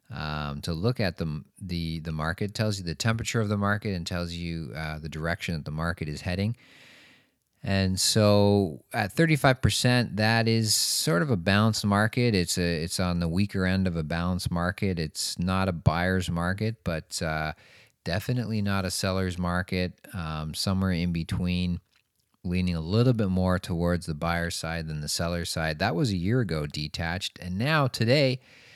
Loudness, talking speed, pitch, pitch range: -27 LUFS, 185 wpm, 90 Hz, 85-105 Hz